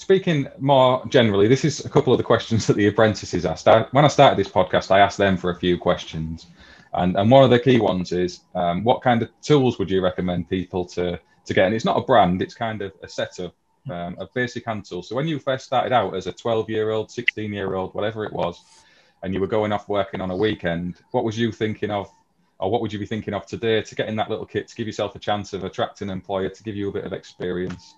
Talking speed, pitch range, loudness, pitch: 255 wpm, 95-120 Hz, -21 LUFS, 105 Hz